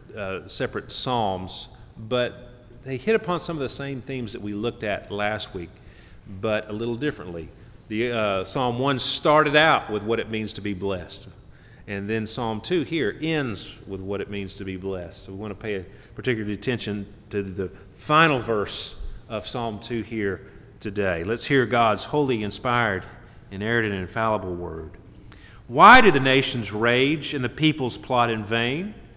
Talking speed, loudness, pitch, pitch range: 175 wpm, -23 LUFS, 110 Hz, 100-125 Hz